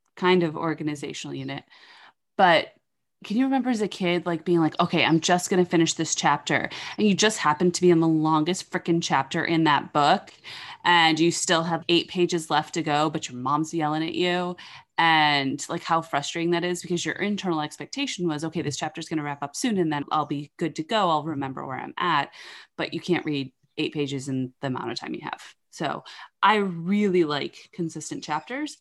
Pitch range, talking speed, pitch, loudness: 150-180 Hz, 210 wpm, 165 Hz, -24 LUFS